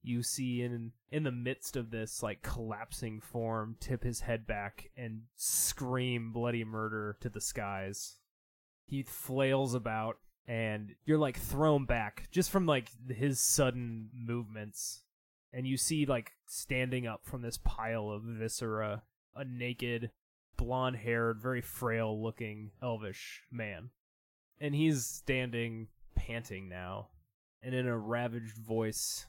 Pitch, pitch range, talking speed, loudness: 115 Hz, 110-125 Hz, 135 wpm, -36 LUFS